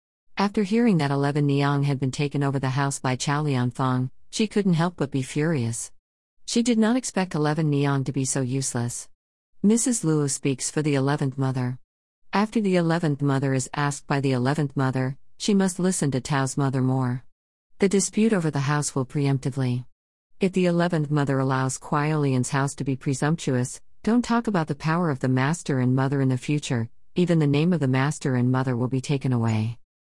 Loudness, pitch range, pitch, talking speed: -24 LUFS, 130-160 Hz, 140 Hz, 190 wpm